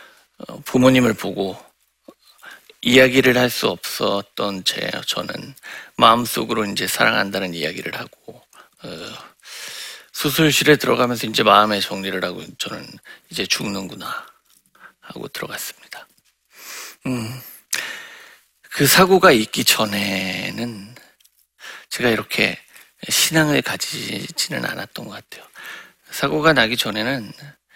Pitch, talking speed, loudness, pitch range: 120 Hz, 240 characters per minute, -18 LUFS, 100-145 Hz